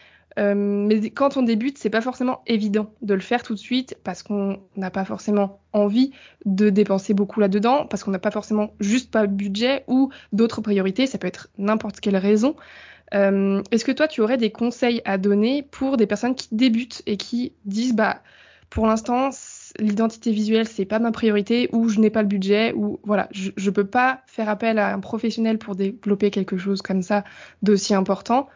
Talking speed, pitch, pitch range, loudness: 200 wpm, 215 Hz, 200-235 Hz, -22 LUFS